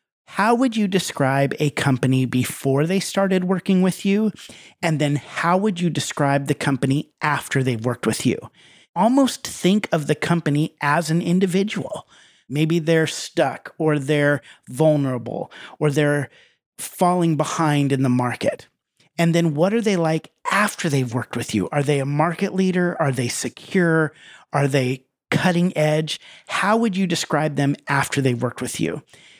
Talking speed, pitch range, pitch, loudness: 160 wpm, 140-180 Hz, 155 Hz, -21 LUFS